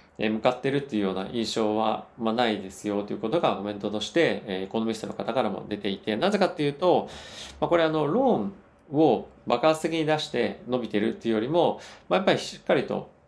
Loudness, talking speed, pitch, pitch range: -26 LUFS, 440 characters per minute, 115 Hz, 105-155 Hz